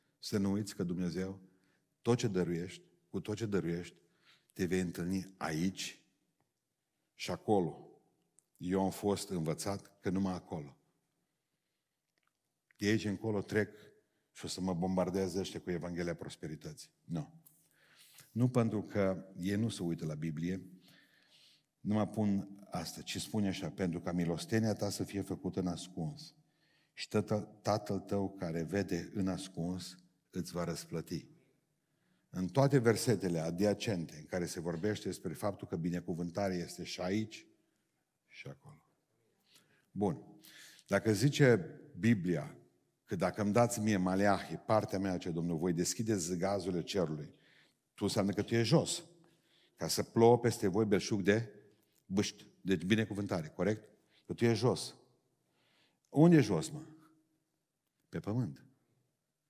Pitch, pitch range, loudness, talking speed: 100 Hz, 90-110 Hz, -35 LUFS, 140 wpm